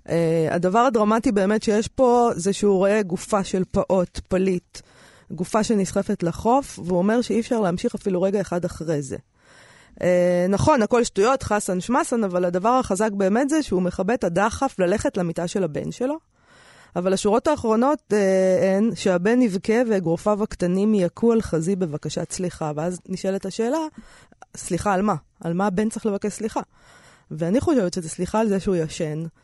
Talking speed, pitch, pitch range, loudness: 165 wpm, 195 Hz, 180-225 Hz, -22 LUFS